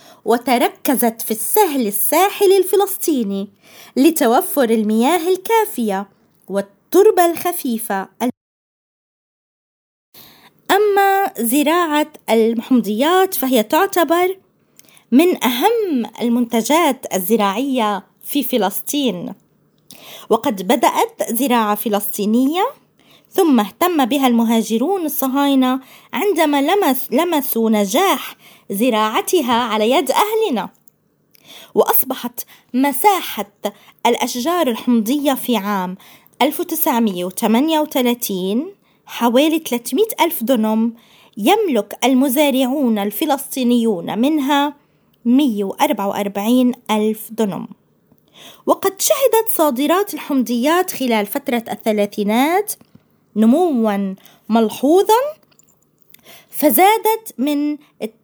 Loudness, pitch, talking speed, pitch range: -17 LUFS, 260 Hz, 70 wpm, 225-320 Hz